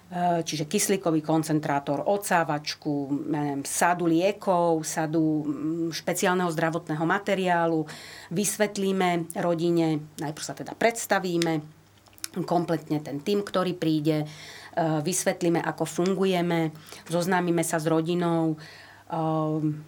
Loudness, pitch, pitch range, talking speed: -26 LUFS, 165 Hz, 155-180 Hz, 85 wpm